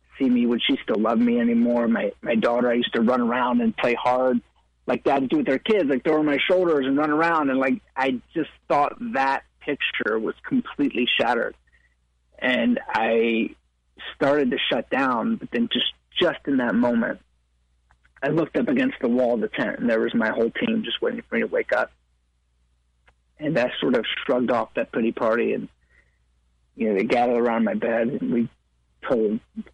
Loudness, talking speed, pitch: -23 LUFS, 200 wpm, 120 Hz